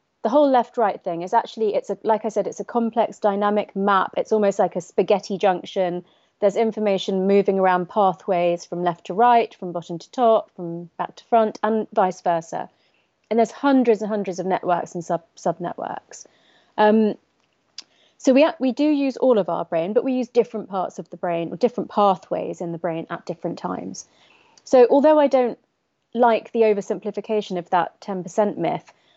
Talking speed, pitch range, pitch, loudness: 185 wpm, 180-230 Hz, 205 Hz, -21 LUFS